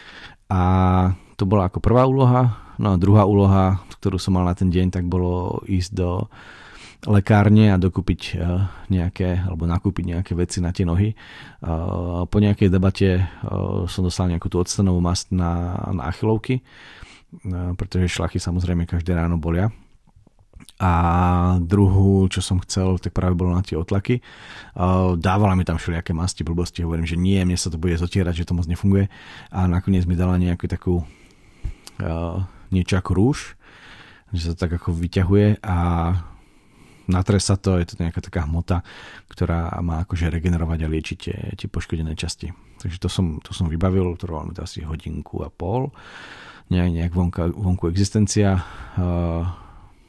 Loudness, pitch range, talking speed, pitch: -21 LUFS, 85-95 Hz, 155 wpm, 90 Hz